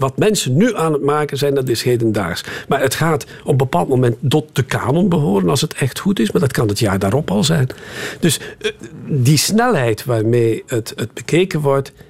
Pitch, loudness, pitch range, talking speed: 145 Hz, -17 LUFS, 125-160 Hz, 210 wpm